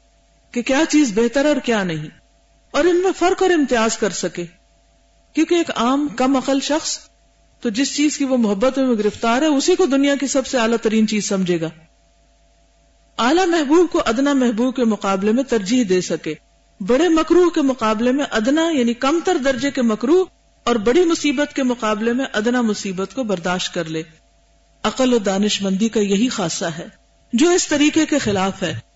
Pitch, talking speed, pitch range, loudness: 245 Hz, 185 wpm, 205-290 Hz, -18 LUFS